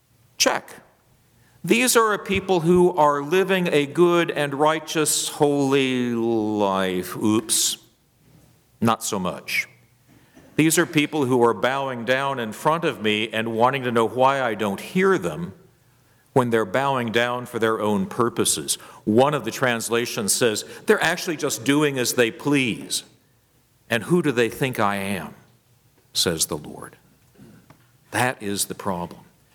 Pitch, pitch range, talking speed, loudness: 130 Hz, 115-150 Hz, 145 wpm, -21 LUFS